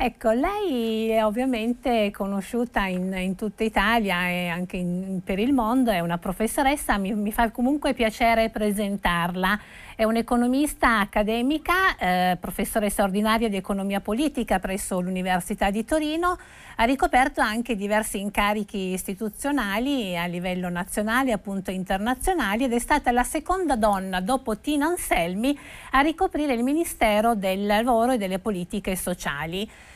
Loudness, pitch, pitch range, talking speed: -24 LUFS, 220 Hz, 195-255 Hz, 135 wpm